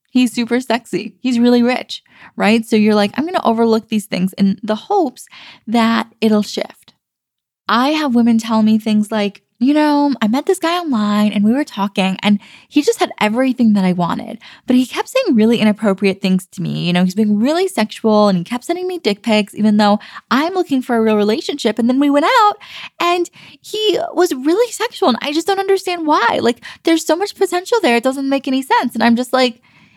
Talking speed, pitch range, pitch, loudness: 215 wpm, 215-310 Hz, 235 Hz, -15 LUFS